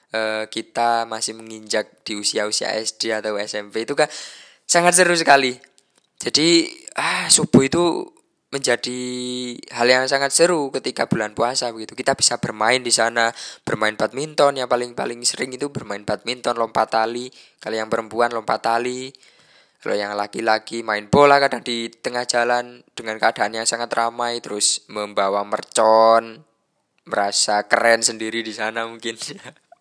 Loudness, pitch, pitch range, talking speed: -19 LUFS, 115 Hz, 110-125 Hz, 135 wpm